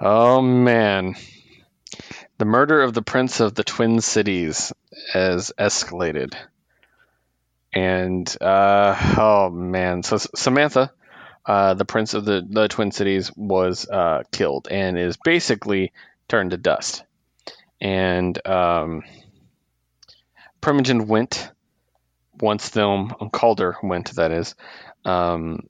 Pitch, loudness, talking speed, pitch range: 100 Hz, -20 LUFS, 110 wpm, 90-110 Hz